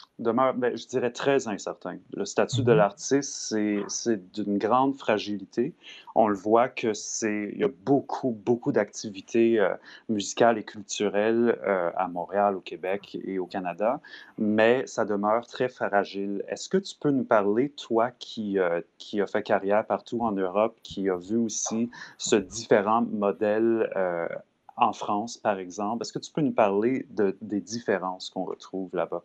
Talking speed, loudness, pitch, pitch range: 165 wpm, -27 LUFS, 105 Hz, 100-115 Hz